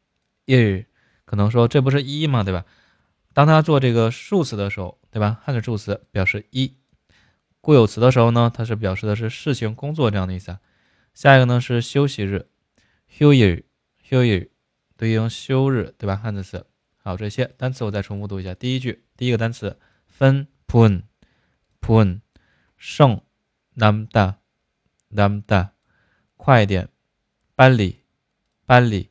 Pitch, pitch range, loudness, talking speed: 110 Hz, 100-130 Hz, -19 LUFS, 245 characters per minute